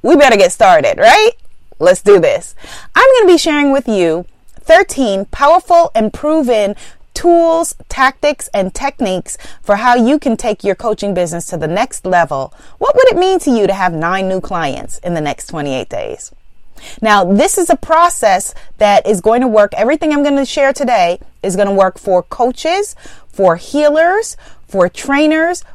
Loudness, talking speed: -12 LUFS, 175 wpm